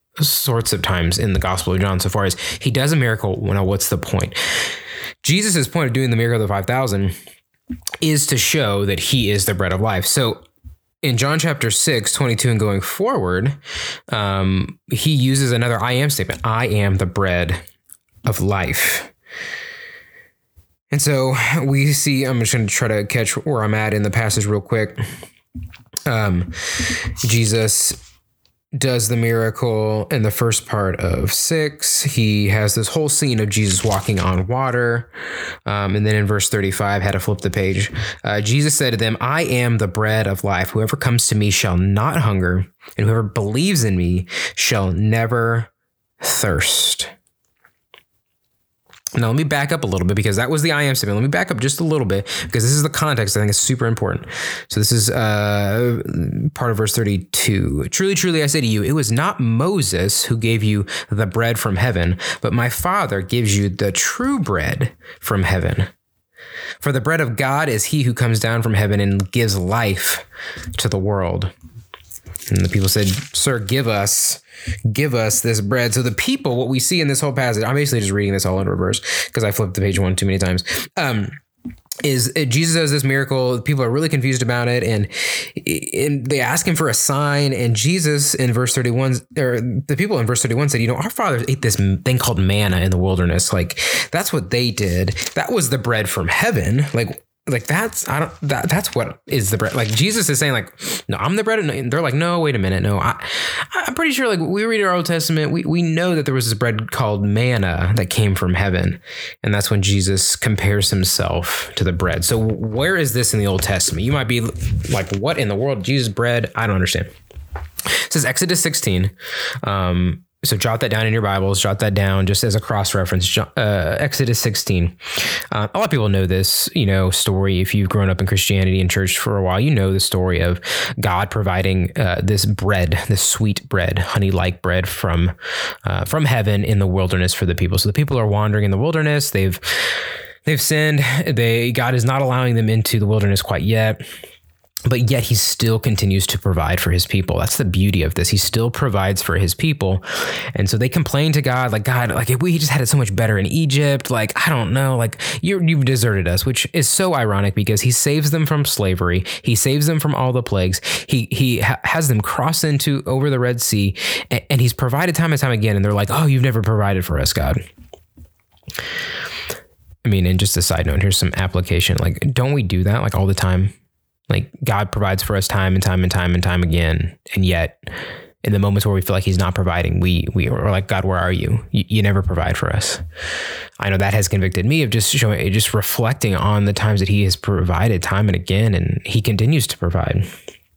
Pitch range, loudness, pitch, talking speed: 95-130 Hz, -18 LUFS, 110 Hz, 210 wpm